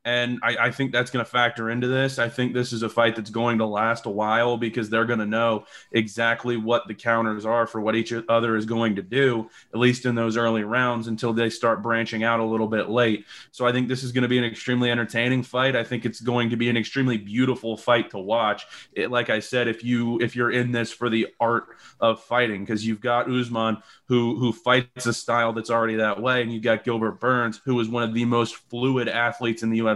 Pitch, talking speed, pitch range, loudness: 115 Hz, 240 wpm, 115-120 Hz, -23 LUFS